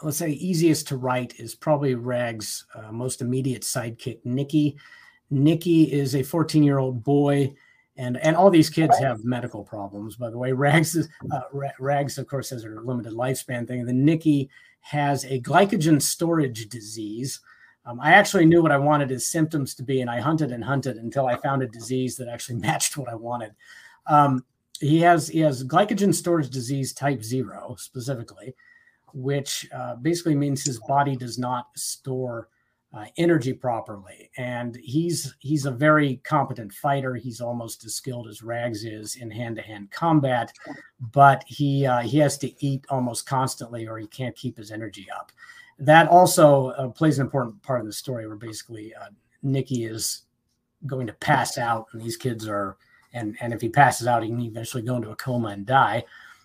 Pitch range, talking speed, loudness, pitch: 120-145 Hz, 180 wpm, -23 LUFS, 130 Hz